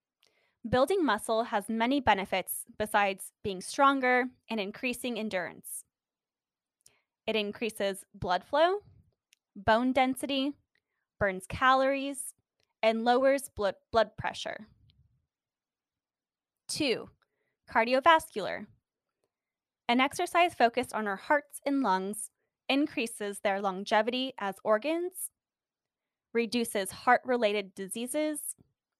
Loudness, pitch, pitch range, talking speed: -30 LUFS, 235 Hz, 205-275 Hz, 85 wpm